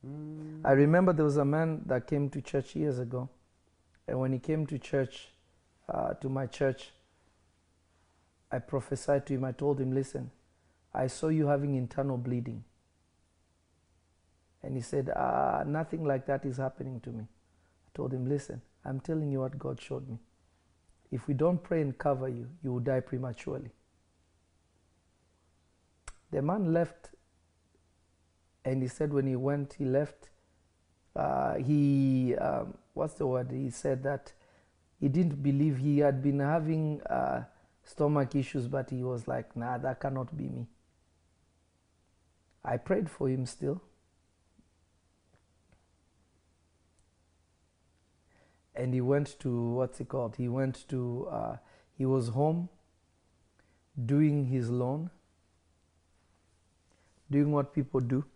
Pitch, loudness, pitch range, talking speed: 125 Hz, -32 LUFS, 85-140 Hz, 140 wpm